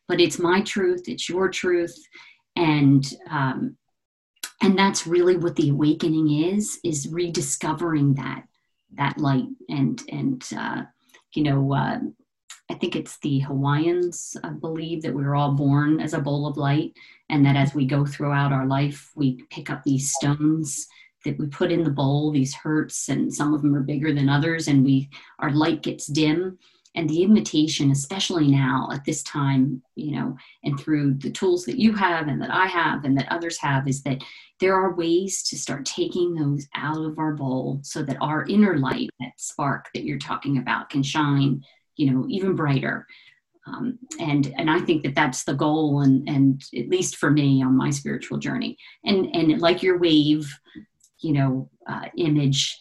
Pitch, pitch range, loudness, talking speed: 150 Hz, 140-175 Hz, -23 LUFS, 185 wpm